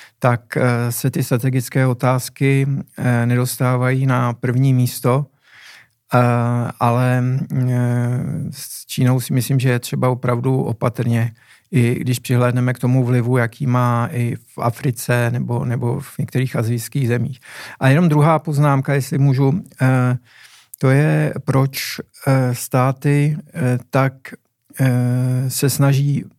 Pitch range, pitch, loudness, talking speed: 125-135 Hz, 130 Hz, -18 LUFS, 110 wpm